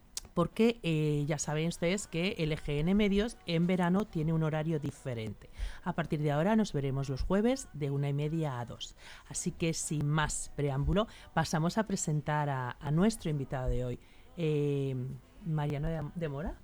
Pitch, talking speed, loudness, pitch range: 155 Hz, 175 wpm, -33 LUFS, 145-175 Hz